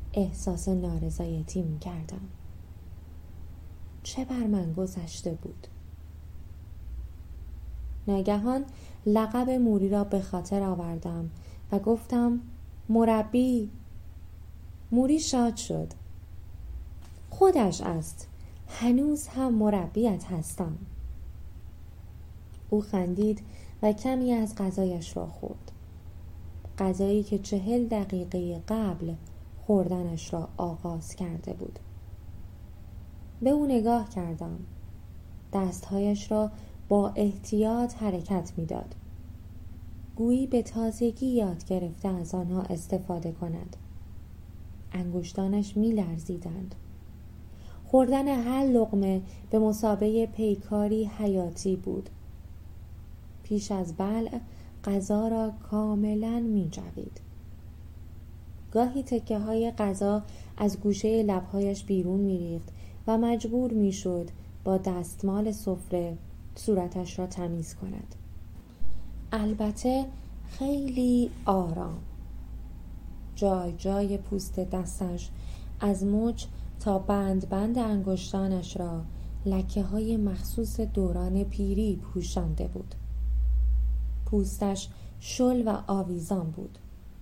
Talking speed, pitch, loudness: 90 wpm, 185 Hz, -29 LUFS